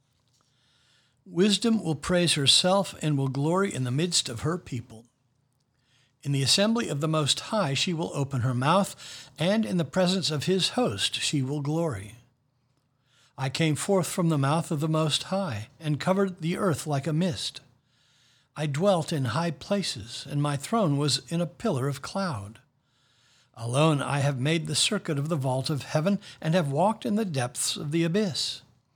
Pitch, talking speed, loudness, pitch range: 145 Hz, 180 wpm, -26 LUFS, 130-175 Hz